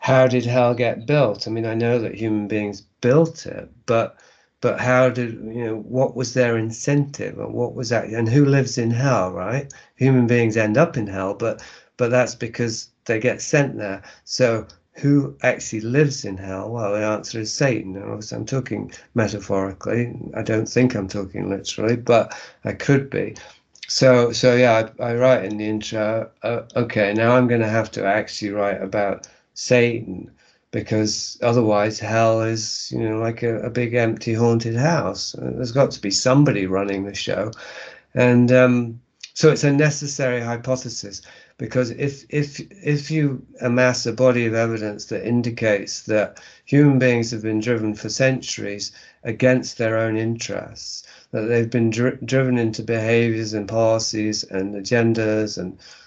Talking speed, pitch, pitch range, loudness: 170 wpm, 115 Hz, 110-125 Hz, -21 LUFS